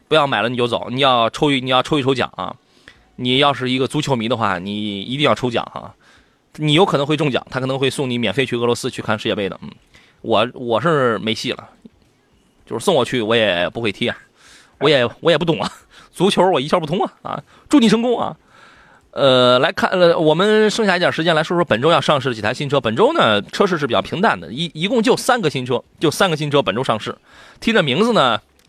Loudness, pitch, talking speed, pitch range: -17 LUFS, 140 Hz, 330 characters per minute, 125-160 Hz